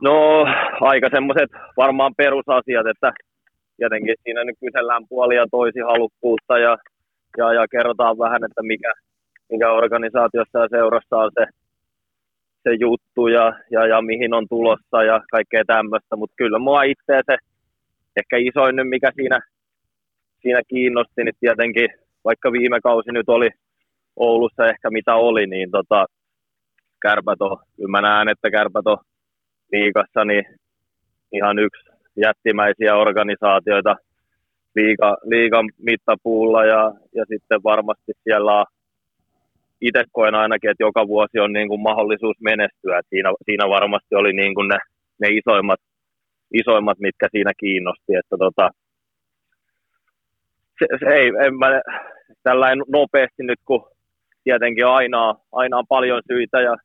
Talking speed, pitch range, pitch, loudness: 130 wpm, 110-120 Hz, 115 Hz, -18 LUFS